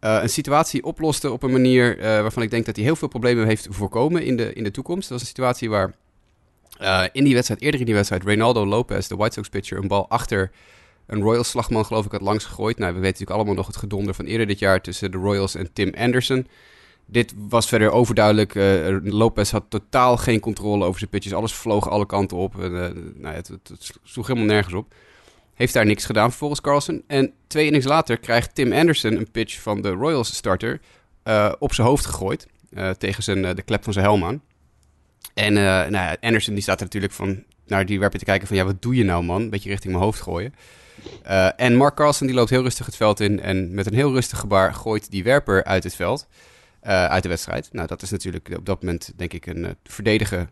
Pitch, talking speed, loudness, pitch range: 105 Hz, 235 wpm, -21 LUFS, 95-120 Hz